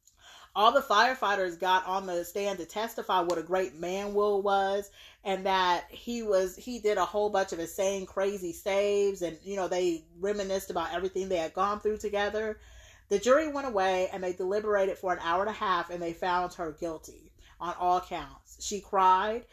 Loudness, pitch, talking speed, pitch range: -29 LUFS, 190 Hz, 195 wpm, 180-205 Hz